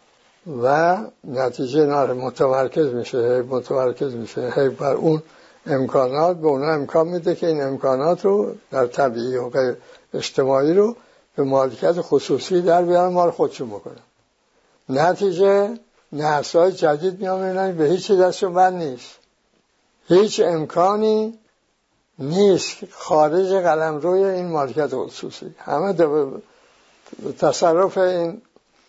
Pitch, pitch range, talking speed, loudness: 170 Hz, 135-190 Hz, 110 wpm, -19 LUFS